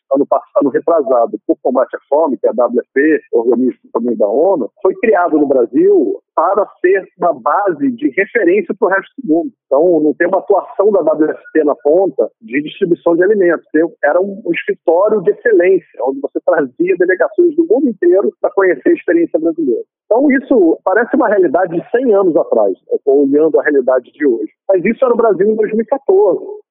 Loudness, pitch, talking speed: -13 LUFS, 270 Hz, 190 wpm